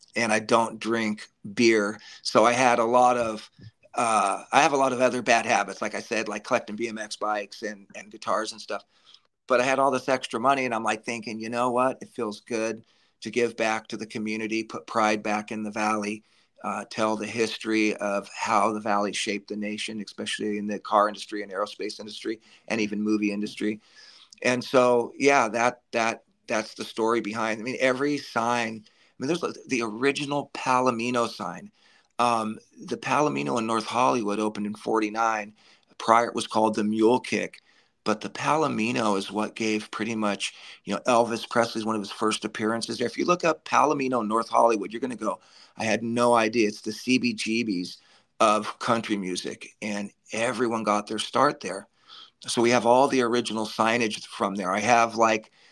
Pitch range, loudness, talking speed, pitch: 105-120 Hz, -25 LUFS, 190 wpm, 110 Hz